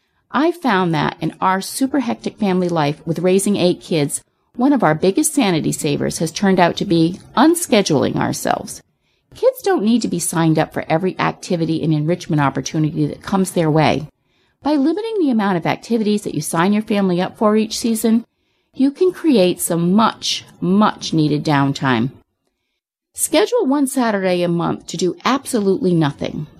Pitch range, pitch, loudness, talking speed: 165-240 Hz, 190 Hz, -17 LUFS, 170 wpm